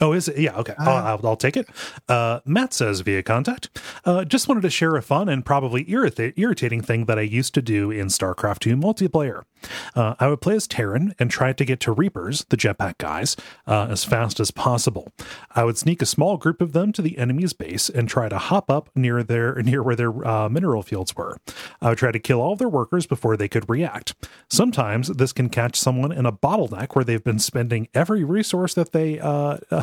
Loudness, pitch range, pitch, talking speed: -22 LUFS, 115-160 Hz, 130 Hz, 225 wpm